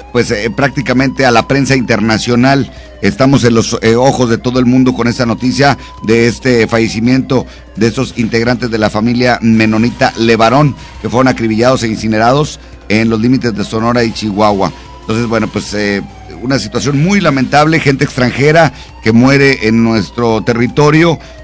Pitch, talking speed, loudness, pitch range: 120 Hz, 160 wpm, -11 LUFS, 110-130 Hz